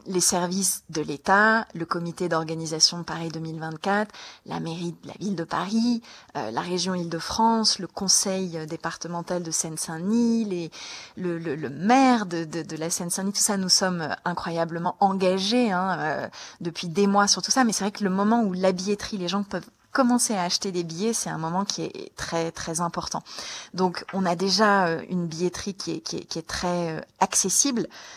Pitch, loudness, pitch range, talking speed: 180 Hz, -25 LUFS, 165-200 Hz, 185 wpm